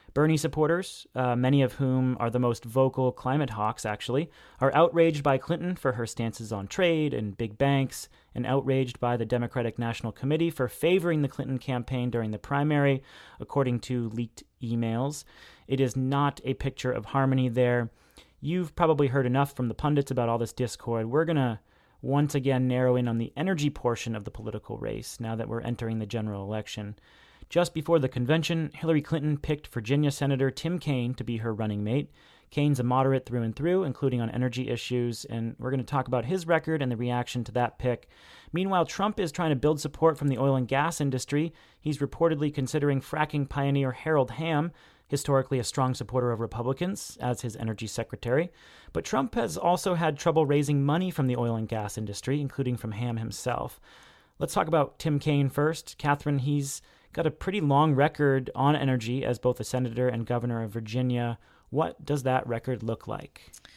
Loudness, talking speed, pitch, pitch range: -28 LUFS, 190 wpm, 130 Hz, 120-145 Hz